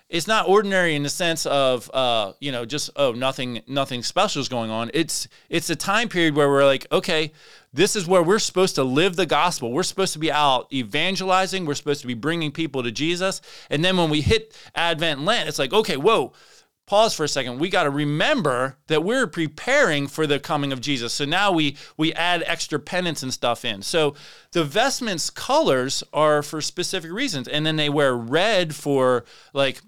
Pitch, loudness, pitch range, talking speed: 150 Hz, -22 LUFS, 140-175 Hz, 205 wpm